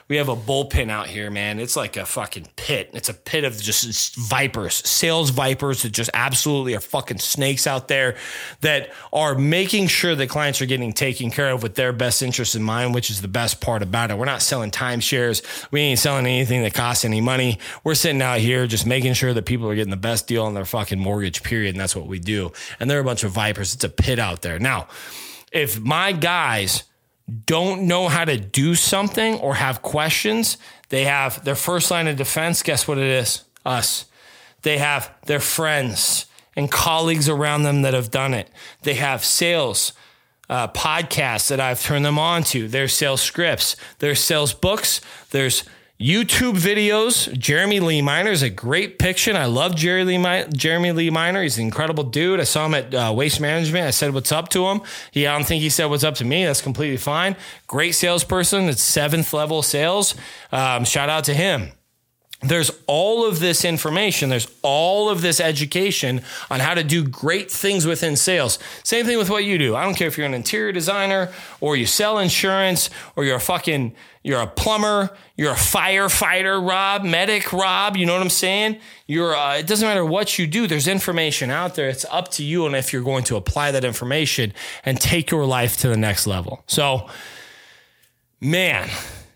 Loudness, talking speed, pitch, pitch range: -19 LUFS, 200 wpm, 145 Hz, 125-170 Hz